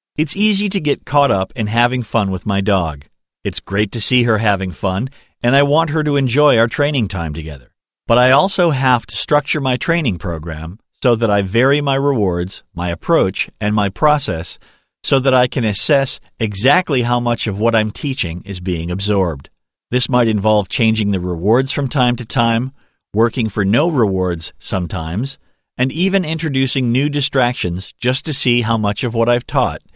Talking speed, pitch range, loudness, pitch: 185 wpm, 100-135 Hz, -16 LUFS, 115 Hz